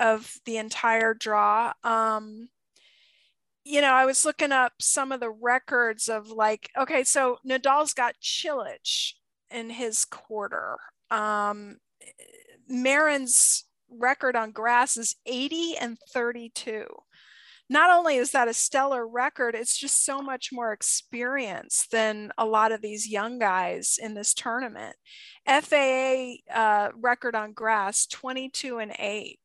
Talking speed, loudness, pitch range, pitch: 130 wpm, -25 LUFS, 220-270 Hz, 240 Hz